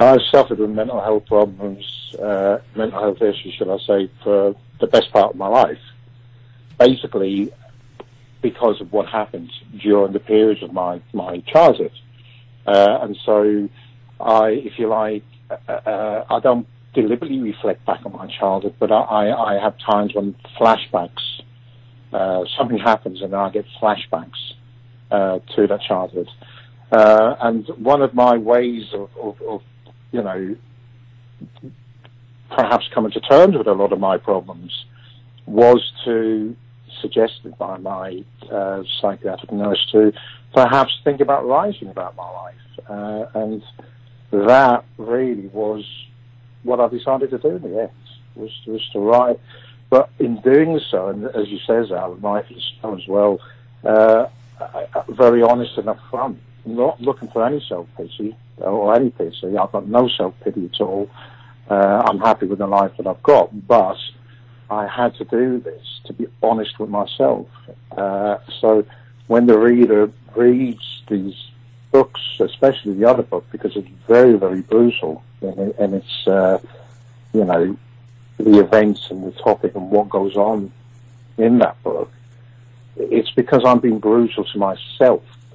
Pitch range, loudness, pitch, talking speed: 105-120 Hz, -17 LUFS, 120 Hz, 150 wpm